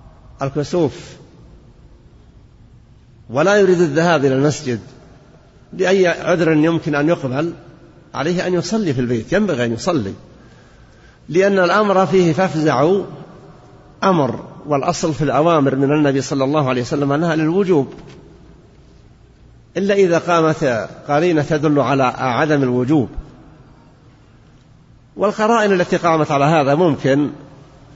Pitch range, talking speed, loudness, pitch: 135-175 Hz, 105 wpm, -16 LUFS, 155 Hz